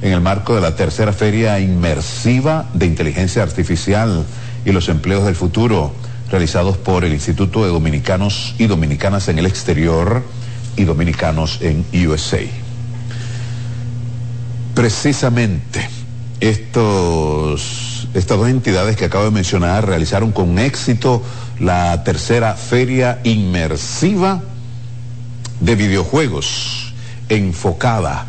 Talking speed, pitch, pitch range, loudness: 105 wpm, 110 Hz, 90-120 Hz, -16 LUFS